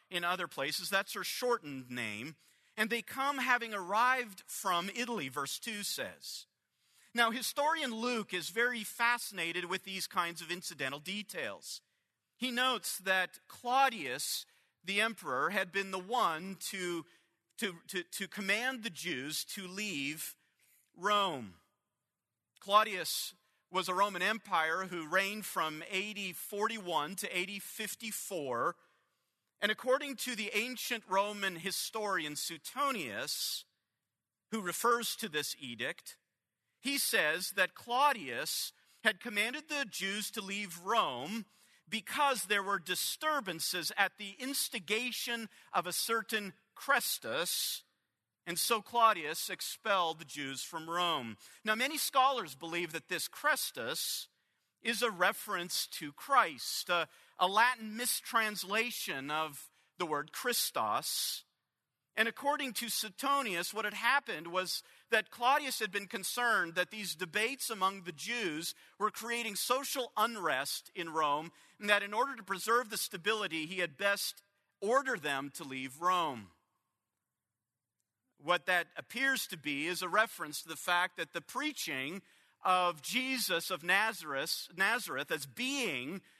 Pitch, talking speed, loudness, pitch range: 200 Hz, 130 wpm, -34 LUFS, 175-235 Hz